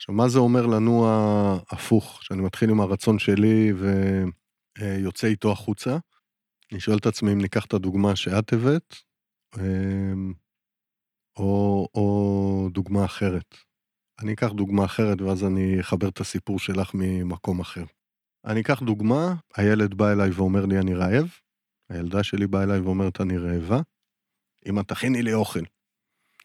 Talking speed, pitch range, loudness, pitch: 140 wpm, 95-110 Hz, -24 LUFS, 100 Hz